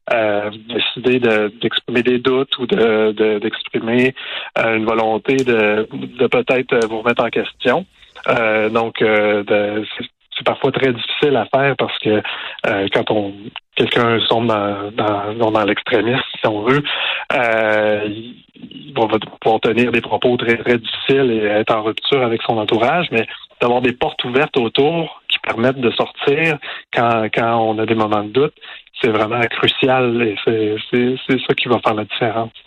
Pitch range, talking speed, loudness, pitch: 105-125 Hz, 165 wpm, -17 LUFS, 115 Hz